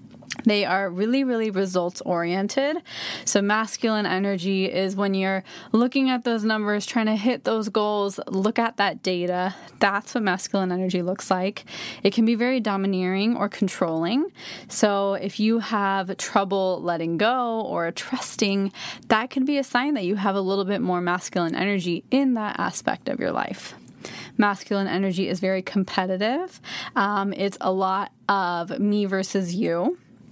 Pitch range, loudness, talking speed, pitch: 190-220 Hz, -24 LUFS, 160 wpm, 200 Hz